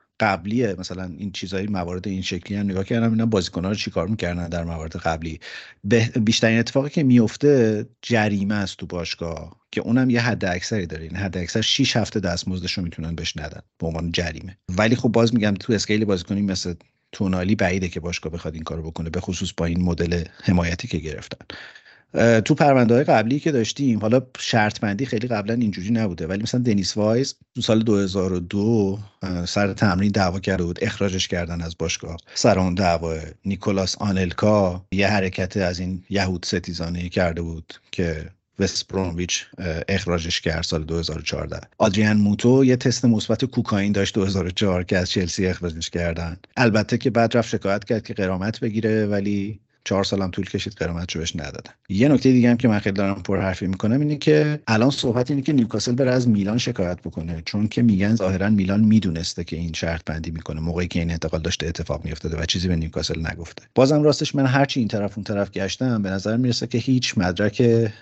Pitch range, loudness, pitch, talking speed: 90-115 Hz, -22 LUFS, 100 Hz, 185 wpm